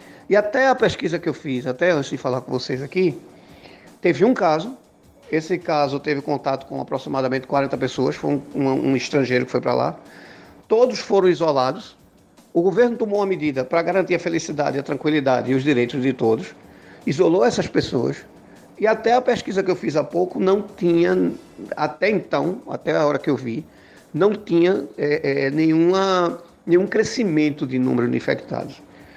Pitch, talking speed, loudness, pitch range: 155 Hz, 165 wpm, -21 LUFS, 135-185 Hz